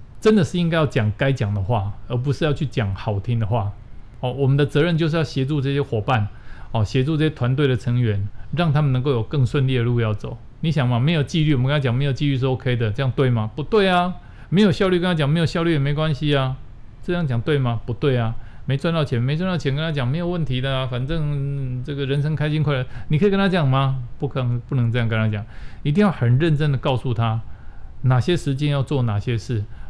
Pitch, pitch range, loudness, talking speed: 135 Hz, 120-150 Hz, -21 LUFS, 350 characters per minute